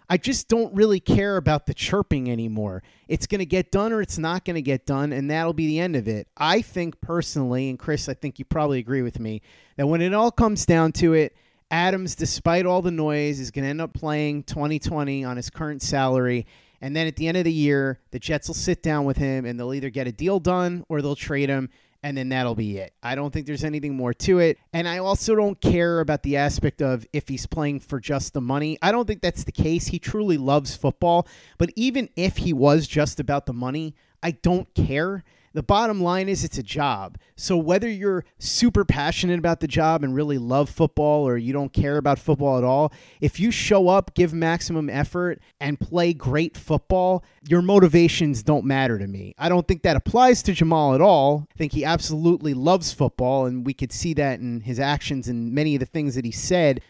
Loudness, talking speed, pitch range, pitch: -23 LUFS, 230 wpm, 135-175 Hz, 150 Hz